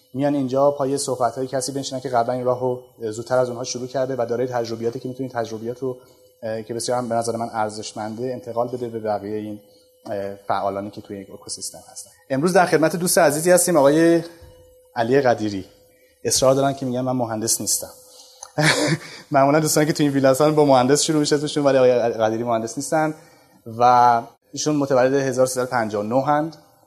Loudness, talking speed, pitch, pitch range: -20 LUFS, 170 wpm, 125 Hz, 115-145 Hz